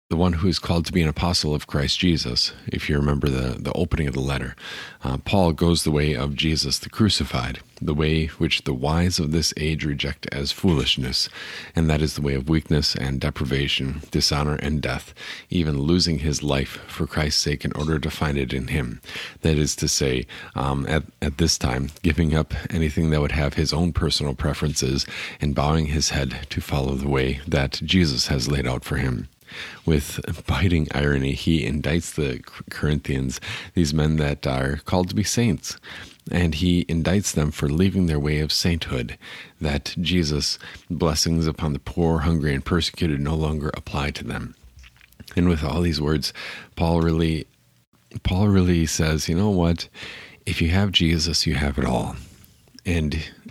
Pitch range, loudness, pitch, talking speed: 70-85 Hz, -23 LUFS, 75 Hz, 180 wpm